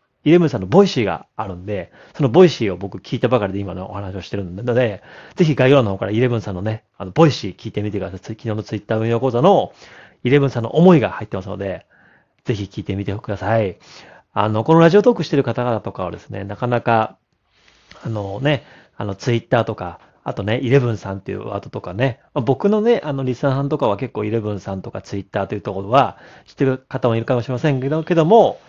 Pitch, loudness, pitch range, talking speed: 115 Hz, -19 LUFS, 100-135 Hz, 470 characters per minute